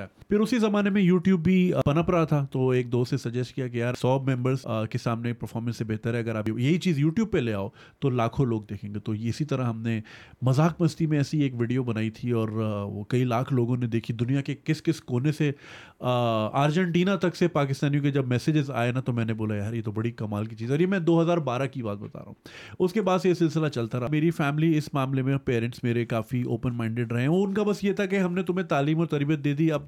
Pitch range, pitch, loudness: 120-160 Hz, 130 Hz, -26 LUFS